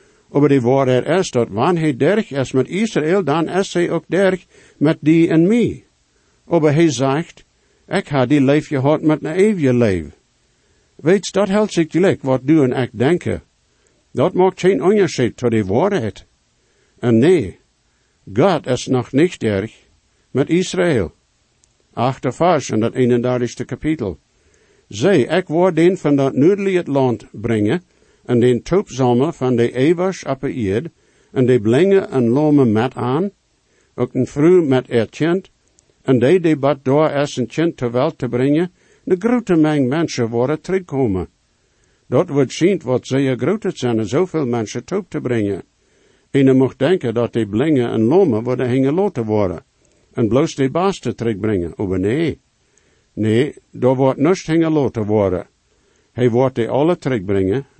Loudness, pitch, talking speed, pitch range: -17 LUFS, 135 Hz, 155 wpm, 120-170 Hz